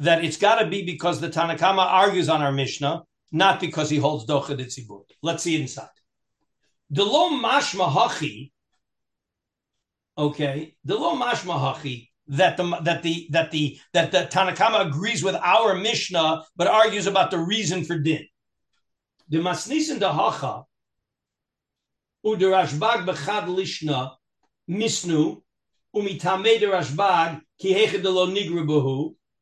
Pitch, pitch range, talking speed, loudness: 170 Hz, 150-190 Hz, 135 wpm, -22 LUFS